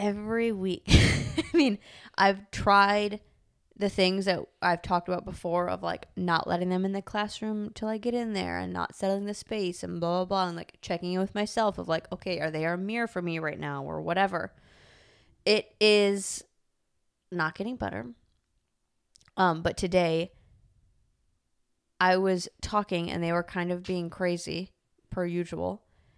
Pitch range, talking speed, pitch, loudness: 170-205 Hz, 170 wpm, 185 Hz, -28 LUFS